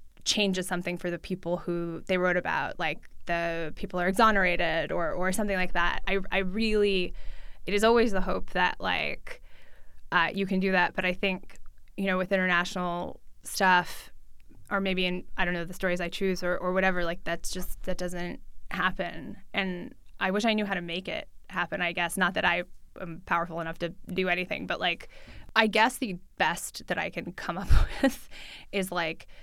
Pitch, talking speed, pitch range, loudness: 185 Hz, 195 wpm, 175-195 Hz, -28 LUFS